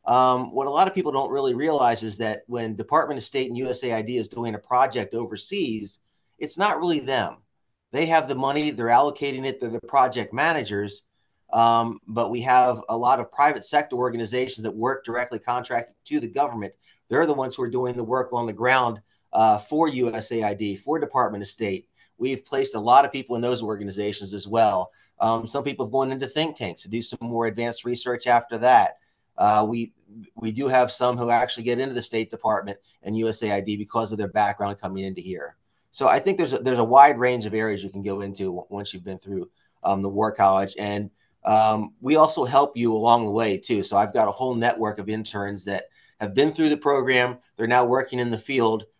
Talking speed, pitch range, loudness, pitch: 215 wpm, 105-130 Hz, -23 LUFS, 115 Hz